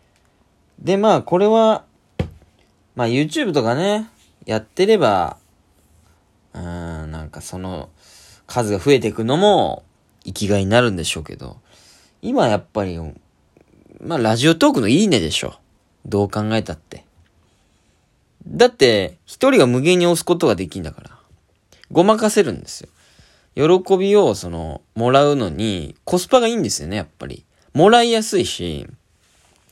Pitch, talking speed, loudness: 105 Hz, 290 characters per minute, -17 LUFS